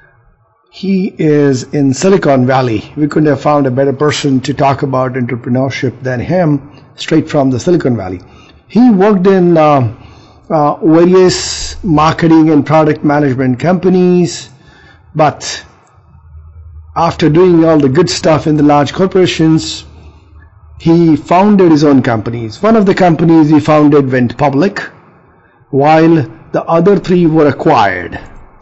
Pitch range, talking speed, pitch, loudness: 125-165 Hz, 135 wpm, 145 Hz, -10 LUFS